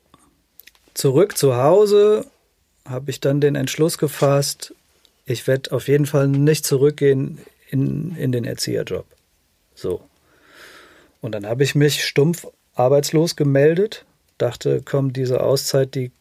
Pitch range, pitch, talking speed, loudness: 135-150 Hz, 140 Hz, 125 wpm, -19 LUFS